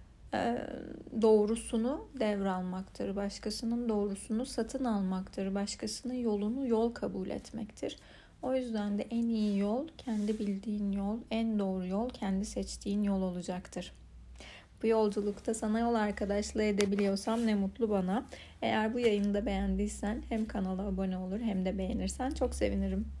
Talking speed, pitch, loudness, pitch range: 130 wpm, 210 Hz, -34 LUFS, 195-225 Hz